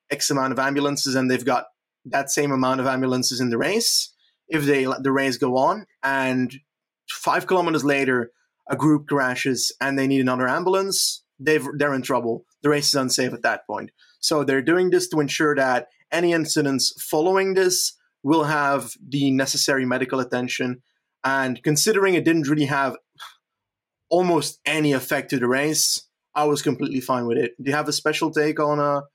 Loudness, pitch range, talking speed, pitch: -21 LUFS, 130-155 Hz, 180 wpm, 140 Hz